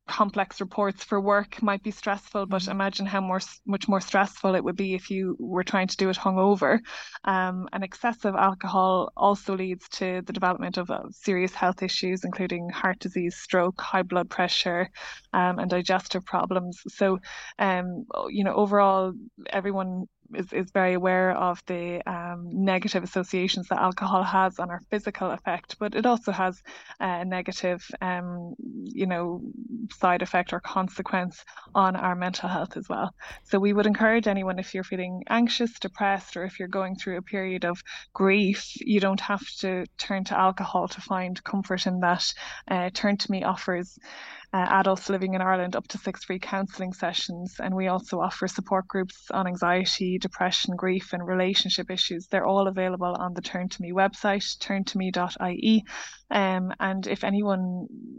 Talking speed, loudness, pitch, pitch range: 170 wpm, -27 LUFS, 190 Hz, 185-200 Hz